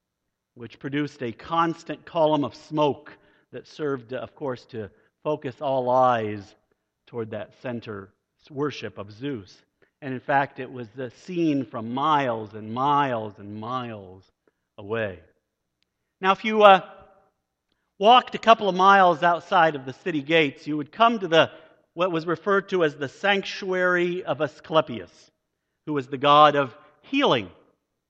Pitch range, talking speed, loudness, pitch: 125-170 Hz, 145 wpm, -23 LUFS, 145 Hz